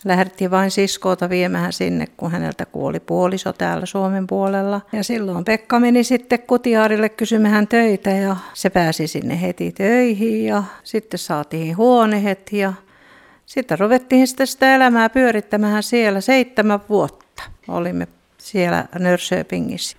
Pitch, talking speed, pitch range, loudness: 200 Hz, 130 wpm, 180-225 Hz, -18 LUFS